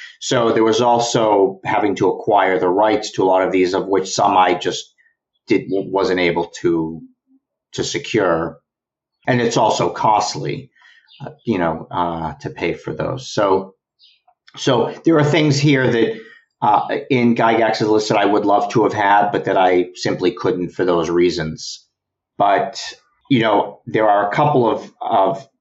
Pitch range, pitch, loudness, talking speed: 95-150 Hz, 115 Hz, -17 LUFS, 170 wpm